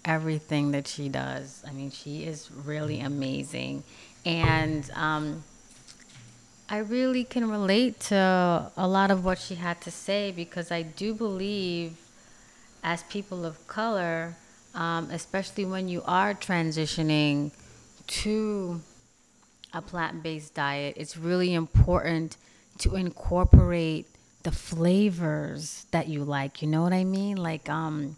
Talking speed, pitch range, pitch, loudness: 130 wpm, 150-185 Hz, 165 Hz, -28 LUFS